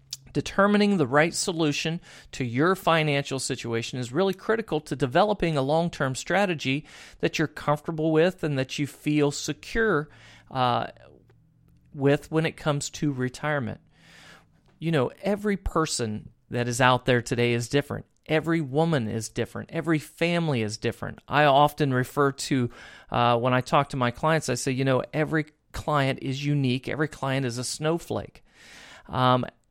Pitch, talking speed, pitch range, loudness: 145 Hz, 155 wpm, 125-160 Hz, -25 LUFS